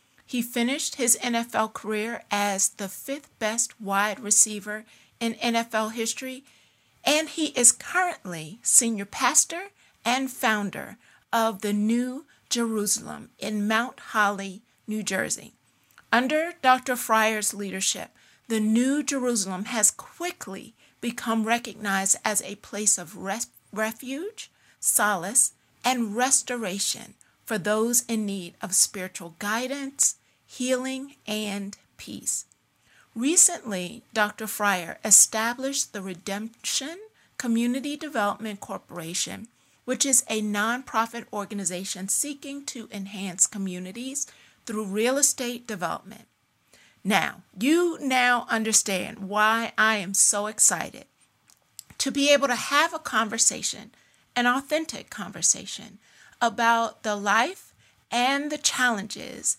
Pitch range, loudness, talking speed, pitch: 205-255 Hz, -24 LUFS, 110 wpm, 225 Hz